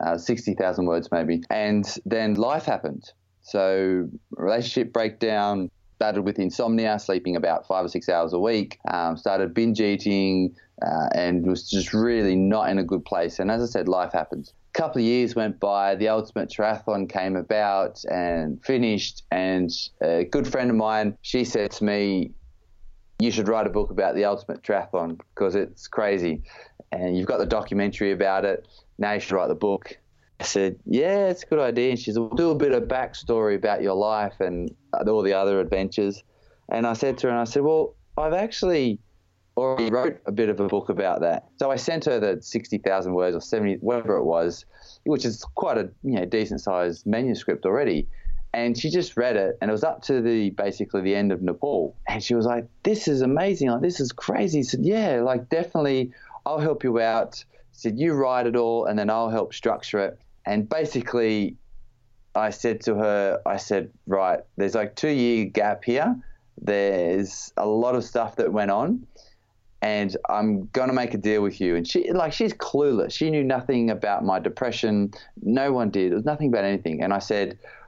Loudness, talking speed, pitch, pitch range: -24 LUFS, 200 wpm, 110 Hz, 95-120 Hz